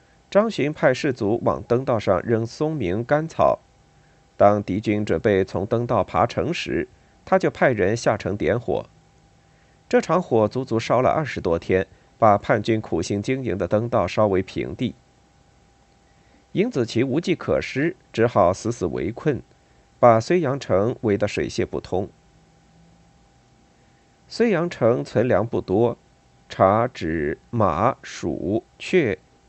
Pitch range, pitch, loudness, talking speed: 95-130 Hz, 115 Hz, -22 LUFS, 190 characters per minute